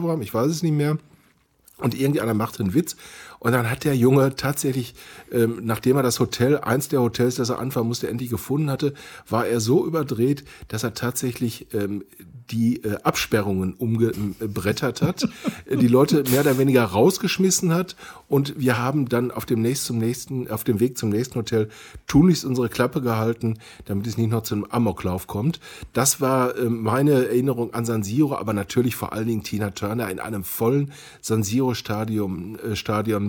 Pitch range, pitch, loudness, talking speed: 110-135 Hz, 120 Hz, -23 LUFS, 180 wpm